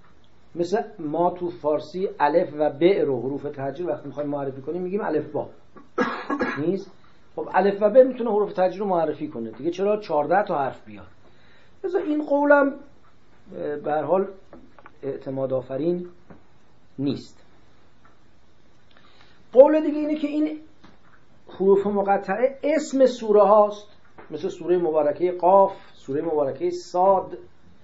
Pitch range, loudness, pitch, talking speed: 150-225 Hz, -23 LUFS, 185 Hz, 125 wpm